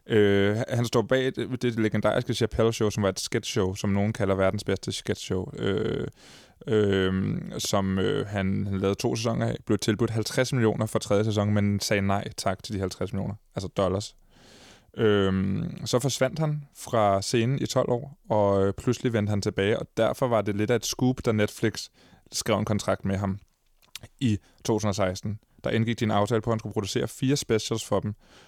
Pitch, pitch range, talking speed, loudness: 105 Hz, 100-120 Hz, 195 wpm, -26 LUFS